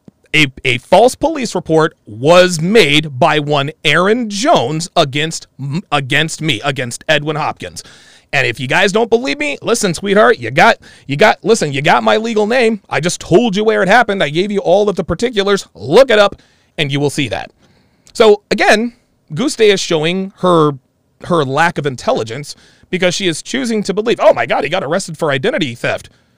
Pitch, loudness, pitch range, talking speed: 175 Hz, -13 LUFS, 150-210 Hz, 190 wpm